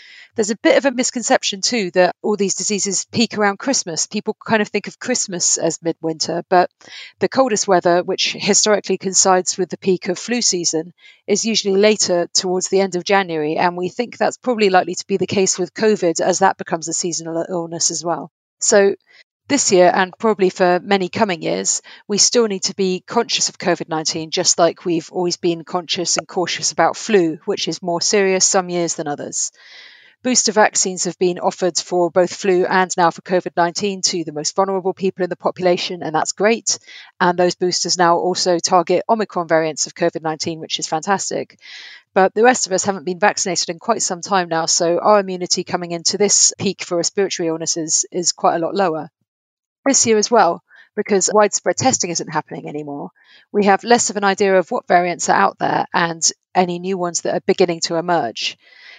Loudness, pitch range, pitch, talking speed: -17 LUFS, 175-200 Hz, 185 Hz, 200 wpm